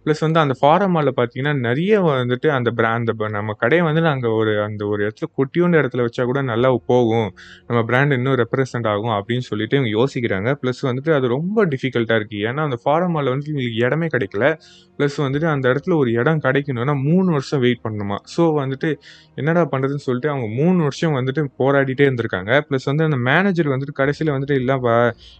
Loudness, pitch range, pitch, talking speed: -19 LUFS, 120-150 Hz, 135 Hz, 180 wpm